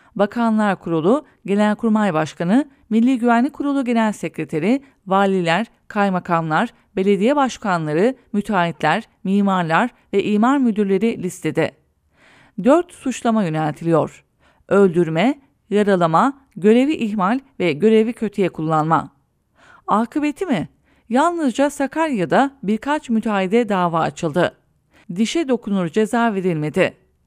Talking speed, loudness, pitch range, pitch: 90 wpm, -19 LUFS, 180-240 Hz, 210 Hz